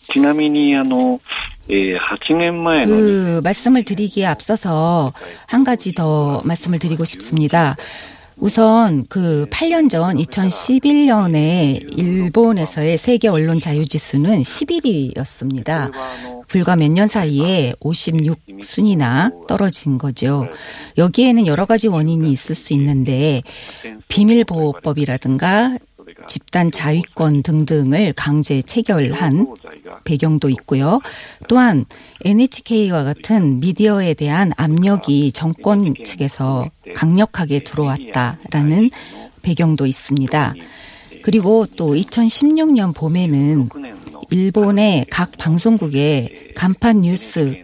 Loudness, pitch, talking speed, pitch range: -16 LUFS, 165 Hz, 215 characters per minute, 145-210 Hz